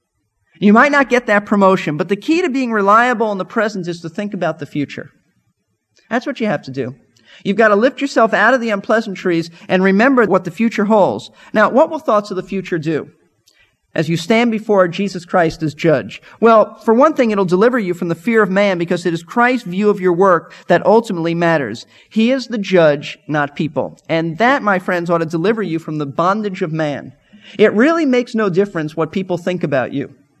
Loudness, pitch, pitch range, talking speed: -15 LUFS, 195 Hz, 165-220 Hz, 215 wpm